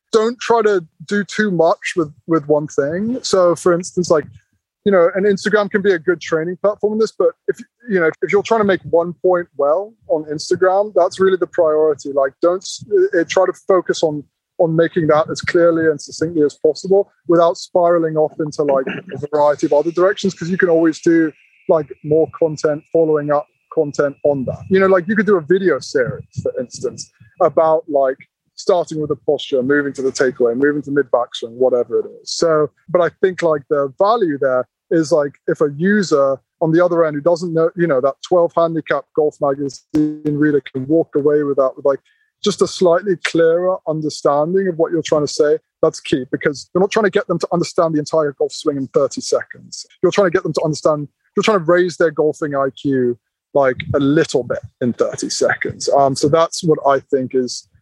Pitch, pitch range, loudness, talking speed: 165 Hz, 150-185 Hz, -17 LUFS, 210 wpm